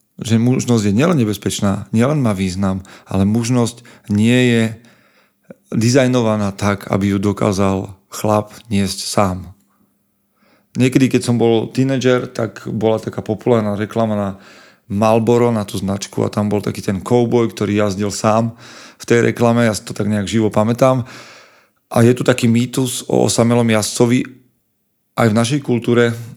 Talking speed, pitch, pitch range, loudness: 150 wpm, 115 Hz, 105-120 Hz, -16 LUFS